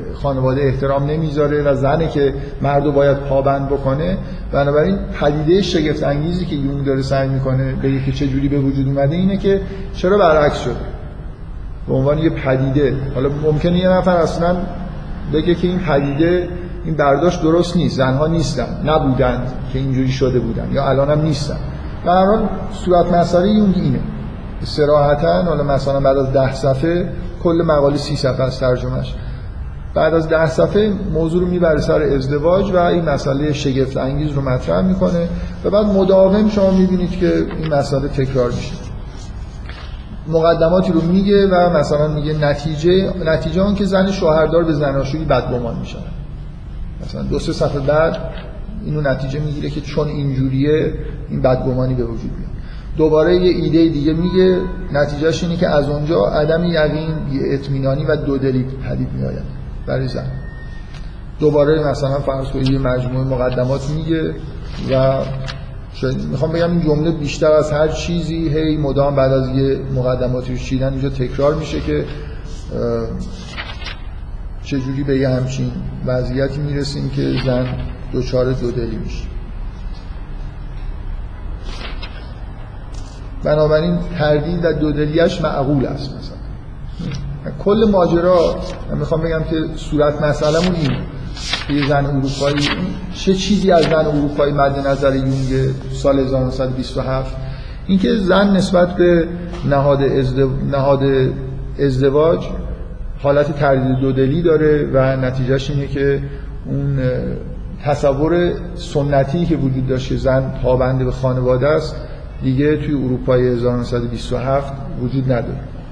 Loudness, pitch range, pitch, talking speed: -17 LUFS, 130-160 Hz, 140 Hz, 135 wpm